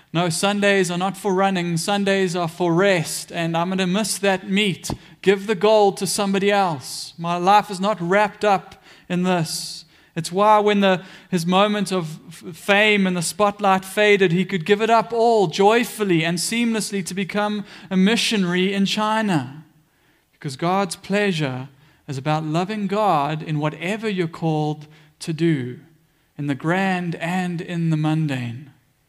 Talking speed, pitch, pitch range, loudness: 160 wpm, 185 Hz, 165-200 Hz, -20 LUFS